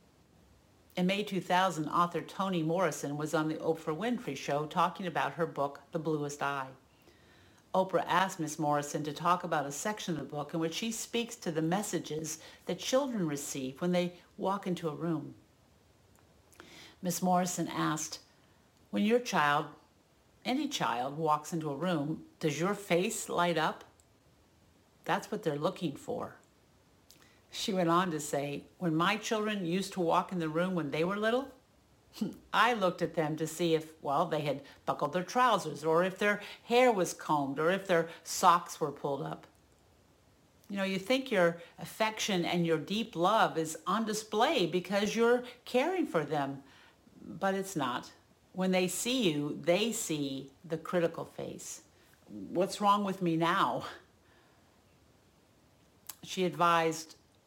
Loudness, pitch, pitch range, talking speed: -32 LUFS, 170 Hz, 155-195 Hz, 155 wpm